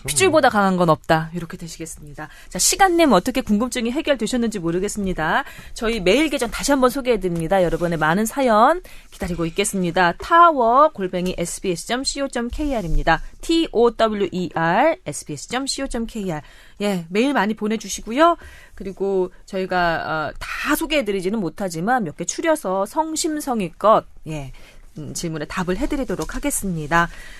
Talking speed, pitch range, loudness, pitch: 350 characters per minute, 175-260 Hz, -20 LUFS, 200 Hz